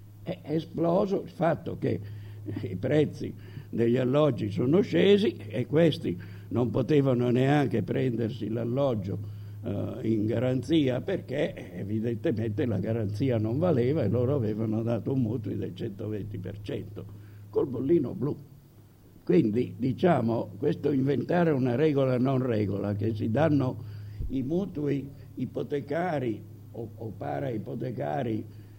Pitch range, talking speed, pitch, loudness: 105-135 Hz, 115 wpm, 115 Hz, -28 LUFS